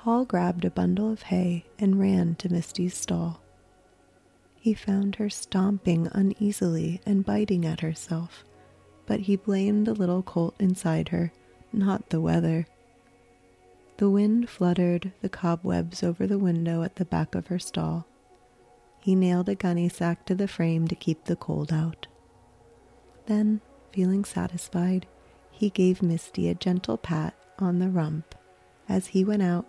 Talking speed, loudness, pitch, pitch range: 150 wpm, -27 LUFS, 175 Hz, 155-195 Hz